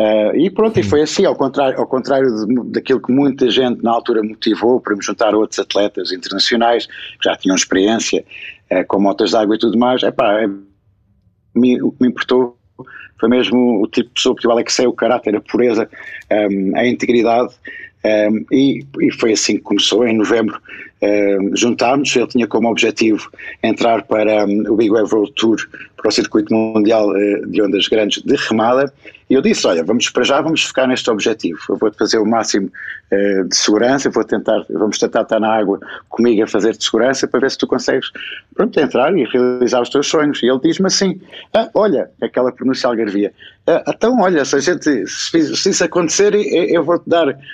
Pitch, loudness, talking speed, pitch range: 125 Hz, -15 LUFS, 200 wpm, 105-140 Hz